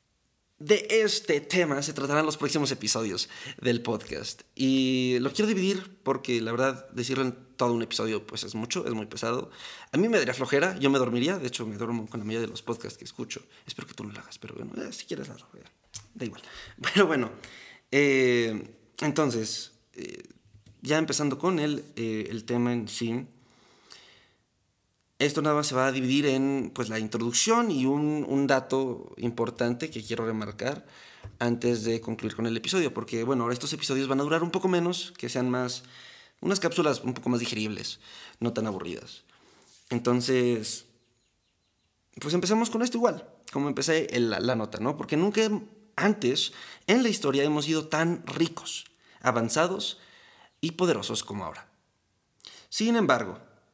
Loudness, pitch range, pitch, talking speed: -28 LUFS, 115-155 Hz, 130 Hz, 170 wpm